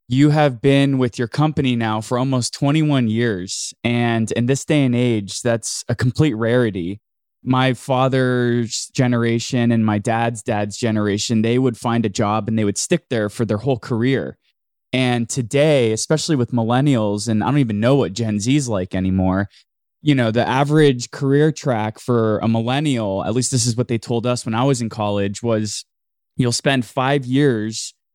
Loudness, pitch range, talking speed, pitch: -19 LUFS, 110-130 Hz, 180 wpm, 120 Hz